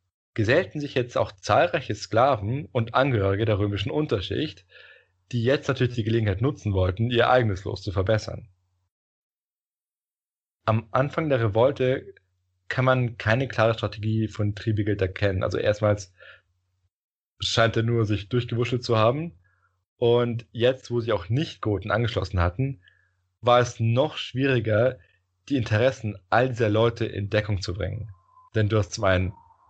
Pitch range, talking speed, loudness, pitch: 100-125 Hz, 140 wpm, -24 LUFS, 110 Hz